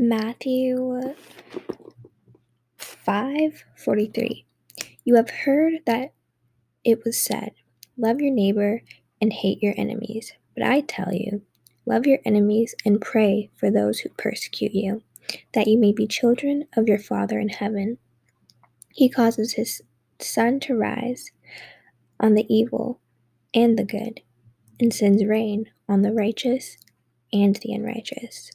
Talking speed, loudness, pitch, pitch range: 130 wpm, -23 LUFS, 220 Hz, 200-240 Hz